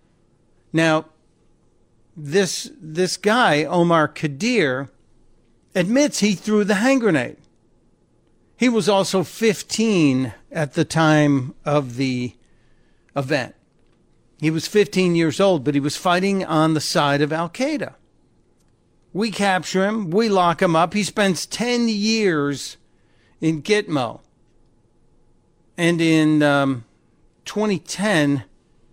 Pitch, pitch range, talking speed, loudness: 165 Hz, 145-200 Hz, 110 wpm, -20 LUFS